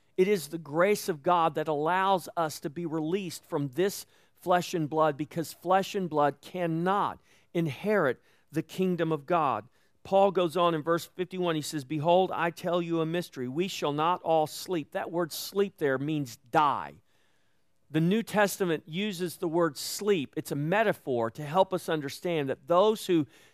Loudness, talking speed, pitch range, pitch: -29 LUFS, 175 wpm, 155-185 Hz, 170 Hz